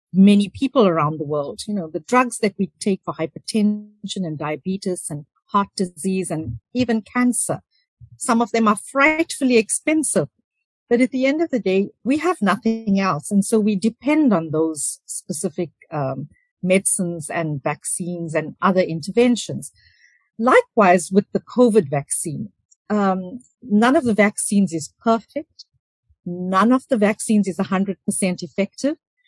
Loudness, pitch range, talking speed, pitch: -20 LUFS, 180-240 Hz, 150 wpm, 200 Hz